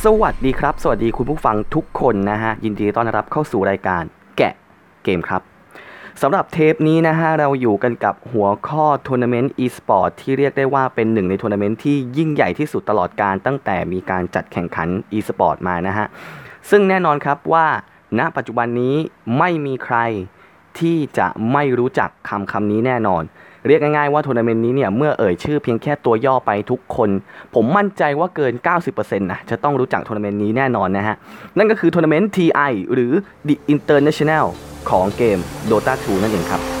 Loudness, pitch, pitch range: -18 LUFS, 125 Hz, 105-150 Hz